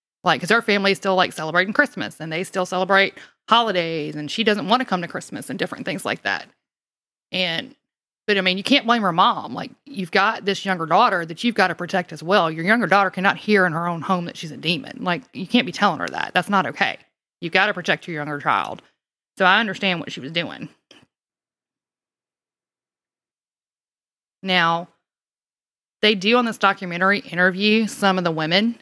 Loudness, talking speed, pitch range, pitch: -20 LUFS, 200 wpm, 175-210 Hz, 190 Hz